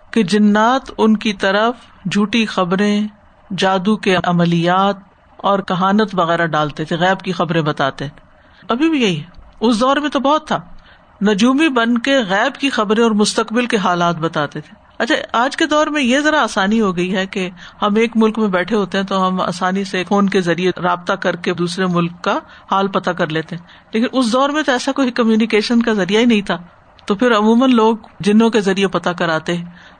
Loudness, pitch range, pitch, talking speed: -16 LUFS, 180-230 Hz, 200 Hz, 200 wpm